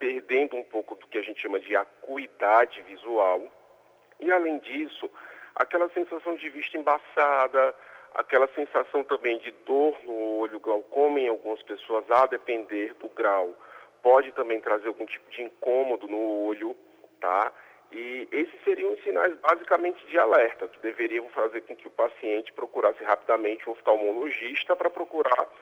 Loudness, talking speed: -27 LUFS, 150 wpm